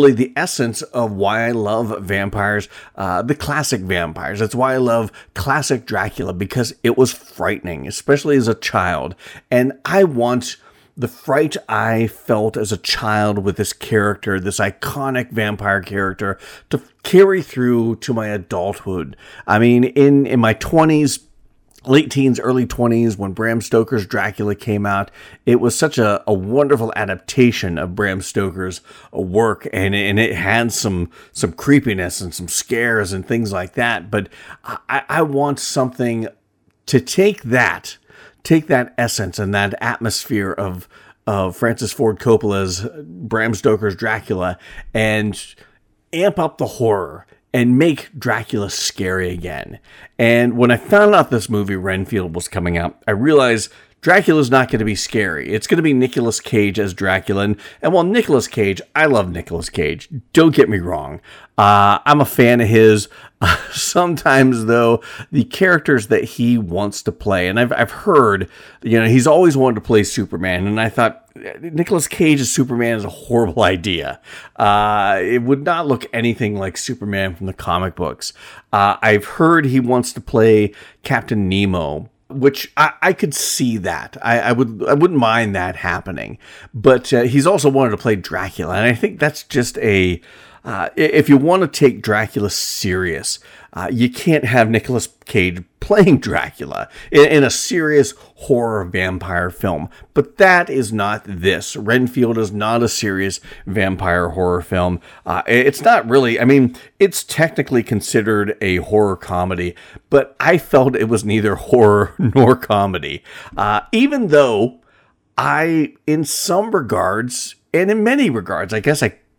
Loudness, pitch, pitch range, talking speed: -16 LUFS, 115 Hz, 100-135 Hz, 160 wpm